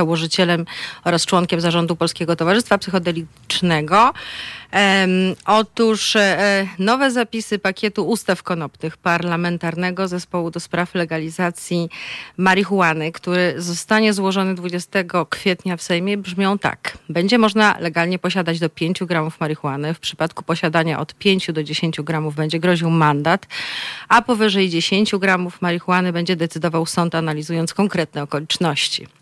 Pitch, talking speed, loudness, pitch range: 175 Hz, 125 wpm, -19 LUFS, 165-195 Hz